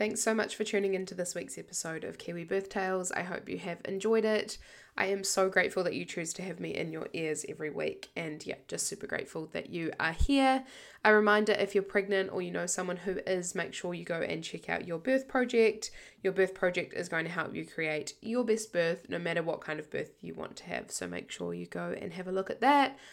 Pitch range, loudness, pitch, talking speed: 170-210 Hz, -32 LUFS, 190 Hz, 250 wpm